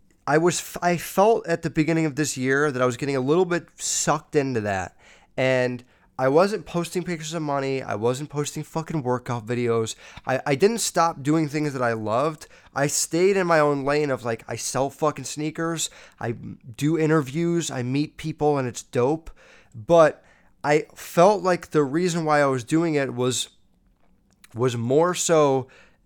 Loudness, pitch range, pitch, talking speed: -23 LUFS, 130-165 Hz, 150 Hz, 180 wpm